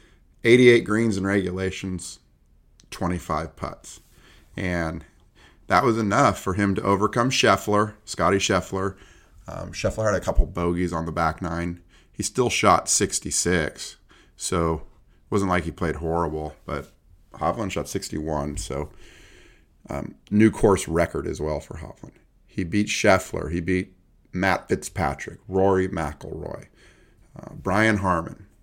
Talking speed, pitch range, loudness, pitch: 130 wpm, 85-100 Hz, -23 LUFS, 95 Hz